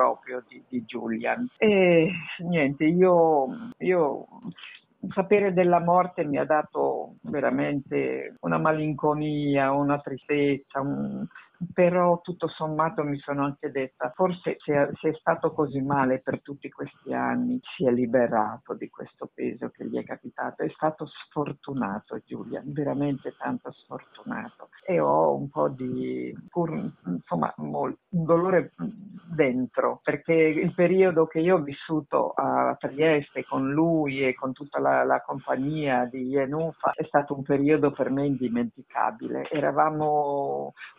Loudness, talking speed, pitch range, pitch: -26 LUFS, 135 wpm, 135-165 Hz, 150 Hz